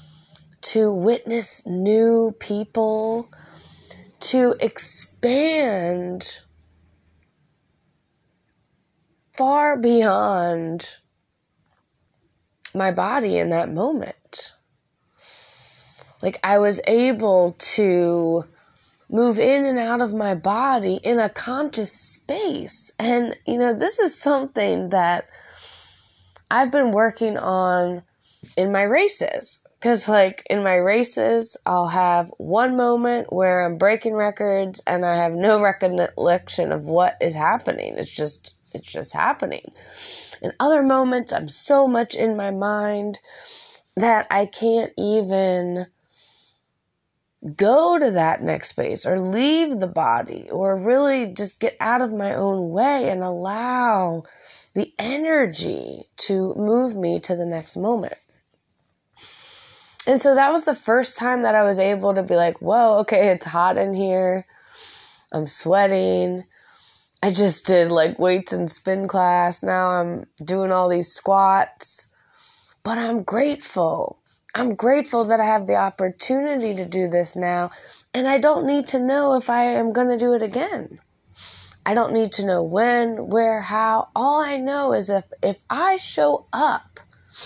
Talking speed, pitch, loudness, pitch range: 130 wpm, 210 Hz, -20 LUFS, 180-245 Hz